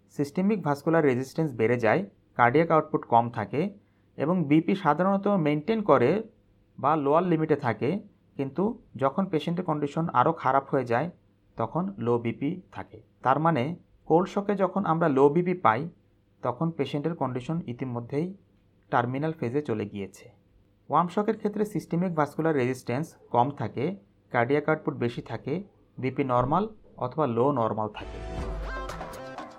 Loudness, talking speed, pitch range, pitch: -27 LUFS, 130 wpm, 120-165 Hz, 145 Hz